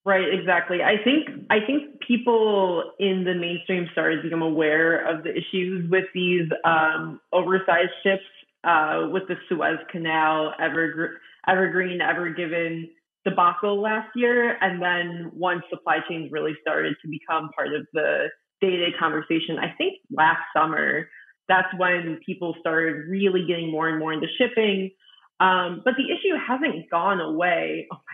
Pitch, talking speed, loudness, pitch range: 180 Hz, 160 wpm, -23 LUFS, 165-195 Hz